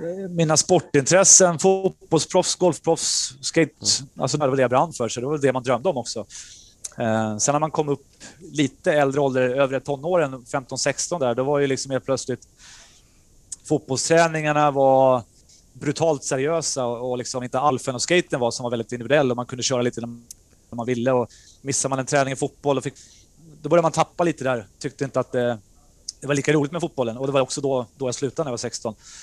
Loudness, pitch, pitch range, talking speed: -21 LUFS, 135 Hz, 120-150 Hz, 195 wpm